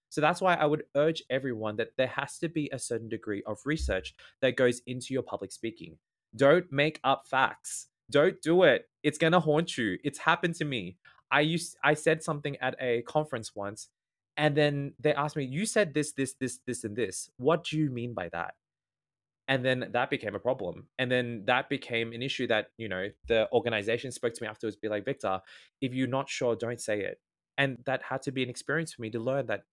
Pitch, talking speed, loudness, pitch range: 130 Hz, 220 wpm, -30 LUFS, 115-150 Hz